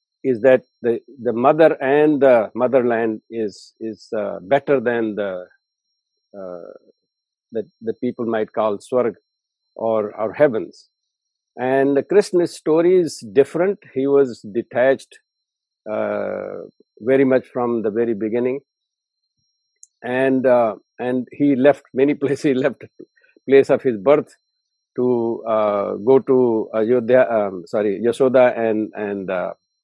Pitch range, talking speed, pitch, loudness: 115-140 Hz, 130 wpm, 130 Hz, -19 LUFS